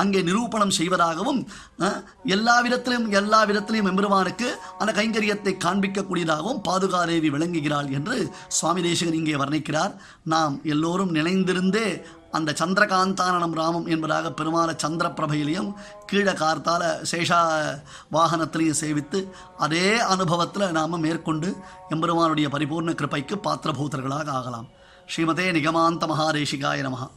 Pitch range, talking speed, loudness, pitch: 155-190 Hz, 100 wpm, -23 LUFS, 170 Hz